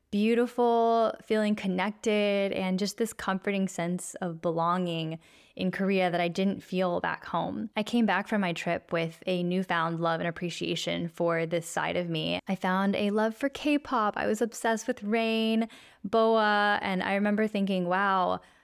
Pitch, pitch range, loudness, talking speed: 195 Hz, 175-220 Hz, -28 LUFS, 170 wpm